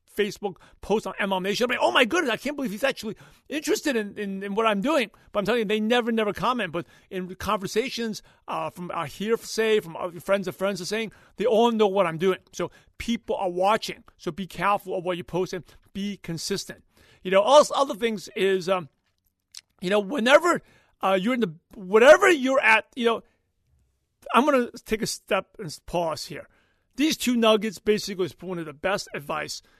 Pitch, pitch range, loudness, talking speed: 210 Hz, 185-235 Hz, -24 LUFS, 205 wpm